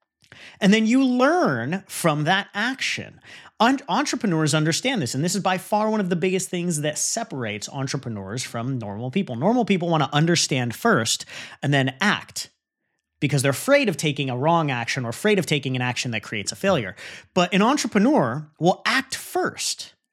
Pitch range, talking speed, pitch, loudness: 135-210 Hz, 175 wpm, 170 Hz, -22 LUFS